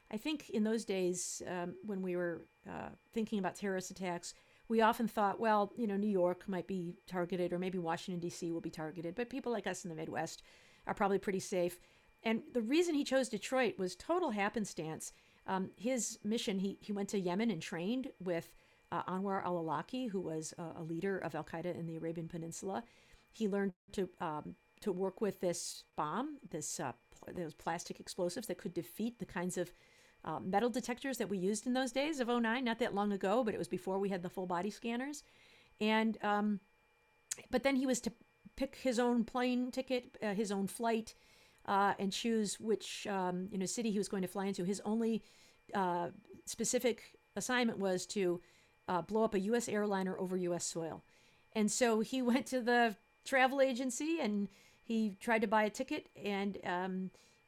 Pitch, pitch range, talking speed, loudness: 200 Hz, 180-230 Hz, 195 wpm, -37 LUFS